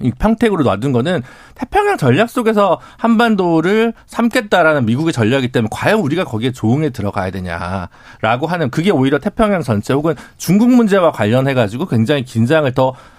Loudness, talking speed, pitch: -15 LUFS, 395 characters per minute, 150 Hz